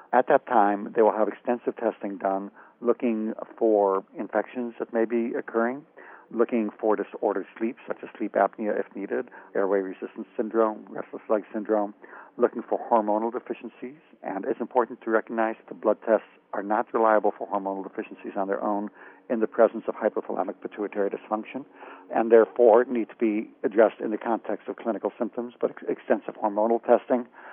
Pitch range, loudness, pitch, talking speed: 105-120 Hz, -26 LUFS, 110 Hz, 170 wpm